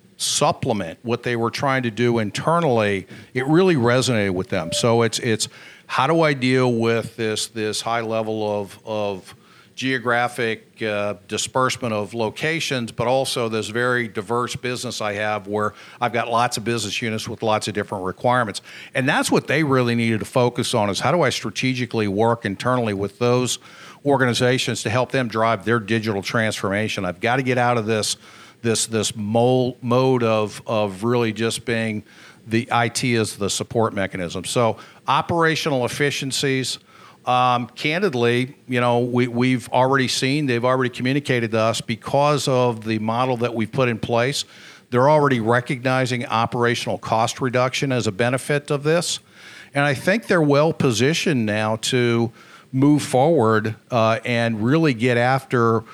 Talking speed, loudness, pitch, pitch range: 160 wpm, -21 LUFS, 120 Hz, 110-130 Hz